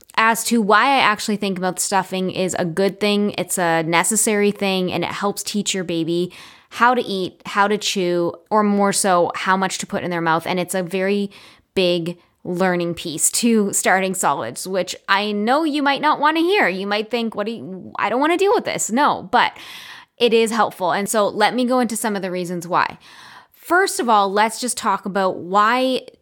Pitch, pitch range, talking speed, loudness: 200 Hz, 180-225 Hz, 215 wpm, -19 LUFS